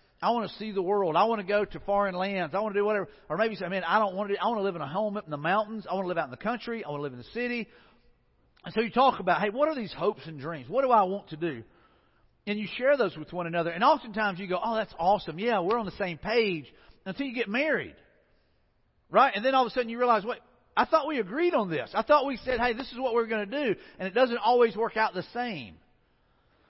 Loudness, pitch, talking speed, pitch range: -28 LUFS, 210 Hz, 295 wpm, 185-240 Hz